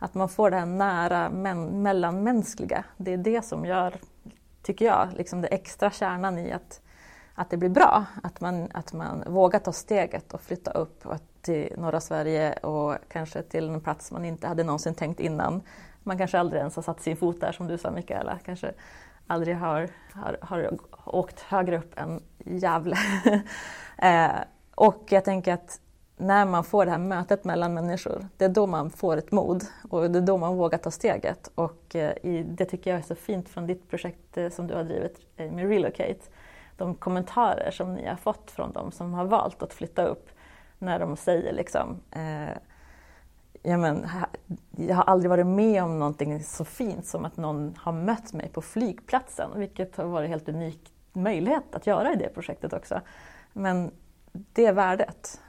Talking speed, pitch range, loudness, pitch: 185 wpm, 165-195 Hz, -27 LUFS, 180 Hz